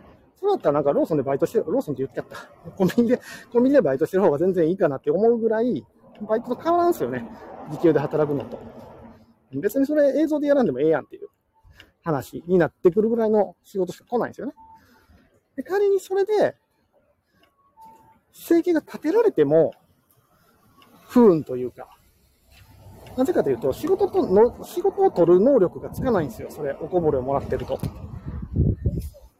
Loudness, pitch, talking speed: -22 LUFS, 220 Hz, 375 characters per minute